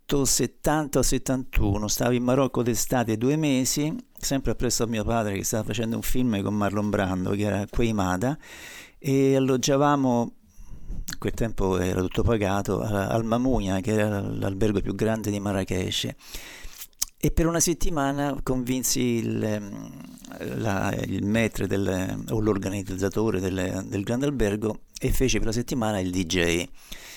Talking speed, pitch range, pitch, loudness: 135 wpm, 100-130 Hz, 110 Hz, -25 LUFS